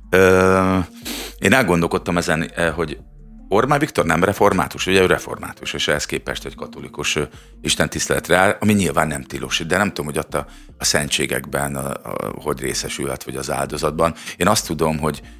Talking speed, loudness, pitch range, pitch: 165 wpm, -19 LUFS, 70-95 Hz, 80 Hz